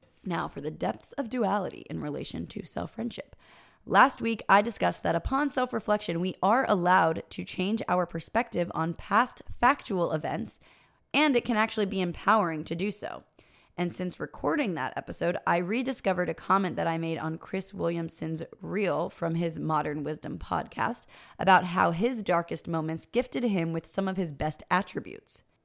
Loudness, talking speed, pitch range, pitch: -29 LUFS, 170 wpm, 165-220 Hz, 185 Hz